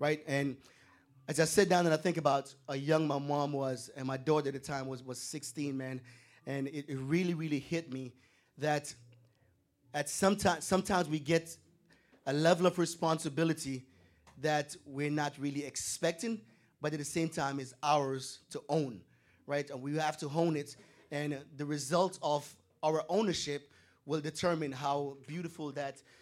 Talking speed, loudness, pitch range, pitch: 170 wpm, -34 LUFS, 135-160 Hz, 145 Hz